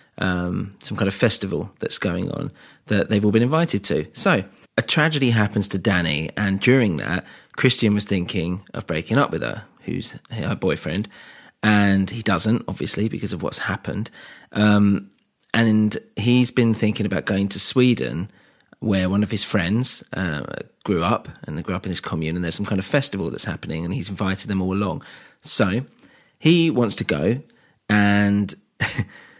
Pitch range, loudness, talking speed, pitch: 95-115 Hz, -22 LUFS, 175 wpm, 105 Hz